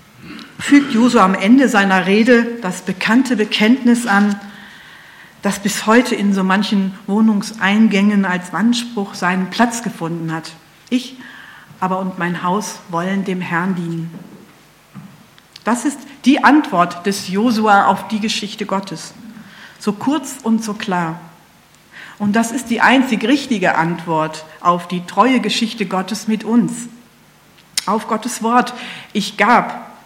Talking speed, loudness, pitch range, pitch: 130 wpm, -16 LUFS, 185-235 Hz, 205 Hz